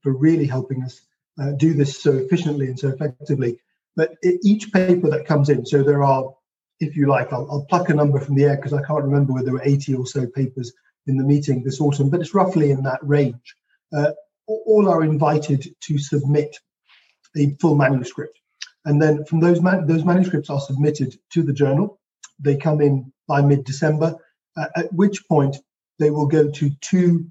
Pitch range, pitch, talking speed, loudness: 140-160 Hz, 145 Hz, 195 wpm, -19 LUFS